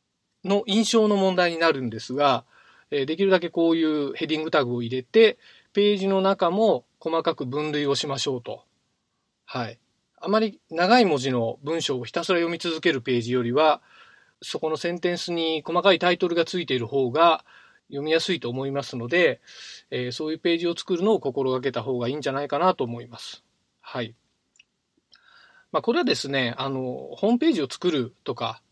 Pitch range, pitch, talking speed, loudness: 135-180 Hz, 160 Hz, 355 characters per minute, -24 LUFS